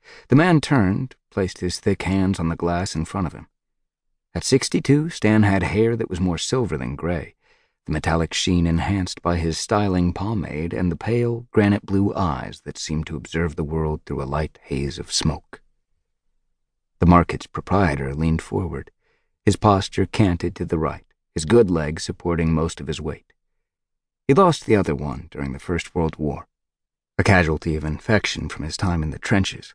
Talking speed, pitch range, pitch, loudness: 185 wpm, 80-100 Hz, 85 Hz, -22 LUFS